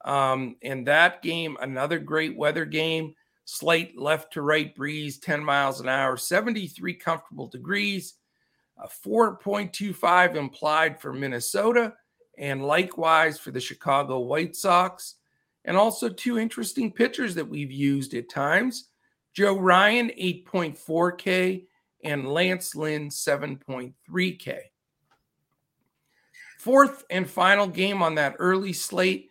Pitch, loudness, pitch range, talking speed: 165 Hz, -24 LUFS, 145-190 Hz, 120 wpm